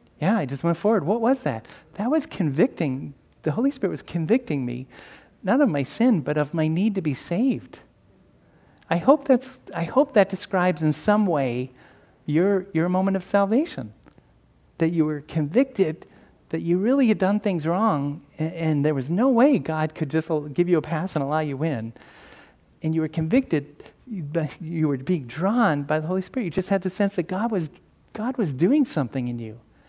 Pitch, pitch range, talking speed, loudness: 175 Hz, 155-210 Hz, 195 wpm, -24 LUFS